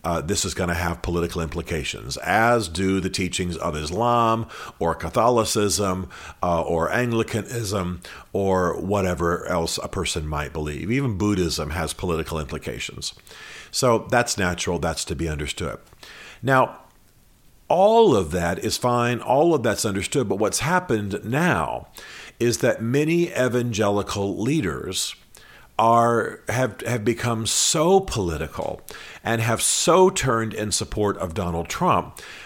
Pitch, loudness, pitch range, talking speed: 100 Hz, -22 LUFS, 85-120 Hz, 135 wpm